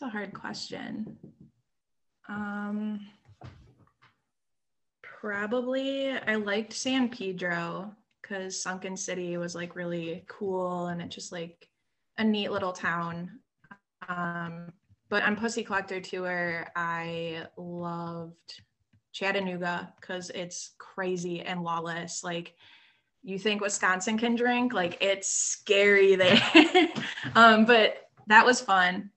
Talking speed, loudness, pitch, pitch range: 110 wpm, -27 LUFS, 190 Hz, 175-210 Hz